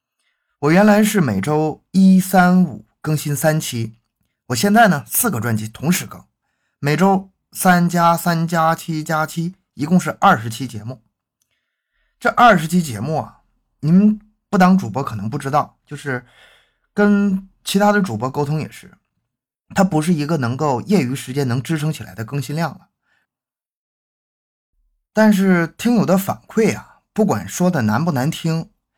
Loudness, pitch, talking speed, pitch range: -17 LUFS, 160 Hz, 220 characters per minute, 130-190 Hz